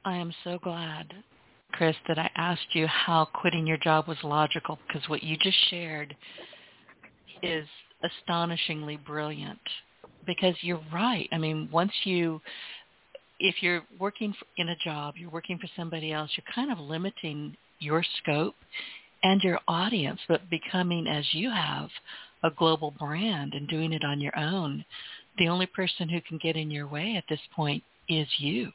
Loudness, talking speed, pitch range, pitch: -29 LUFS, 165 wpm, 155-180 Hz, 165 Hz